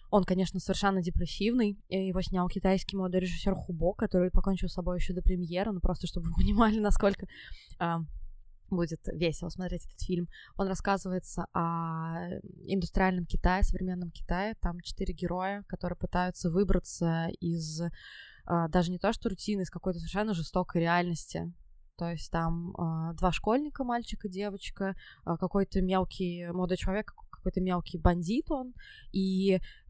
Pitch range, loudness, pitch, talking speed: 170-195 Hz, -32 LUFS, 185 Hz, 145 wpm